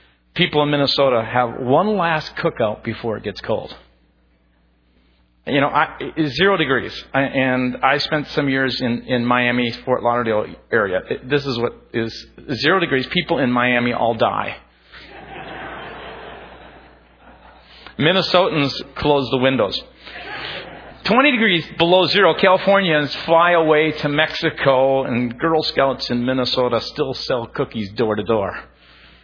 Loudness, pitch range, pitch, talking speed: -18 LUFS, 115-155 Hz, 130 Hz, 135 wpm